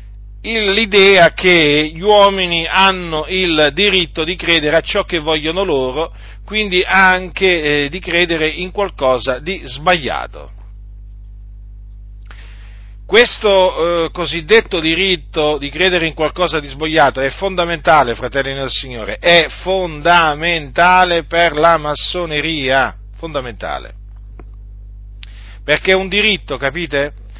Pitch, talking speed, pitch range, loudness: 160 Hz, 105 wpm, 130-185 Hz, -13 LUFS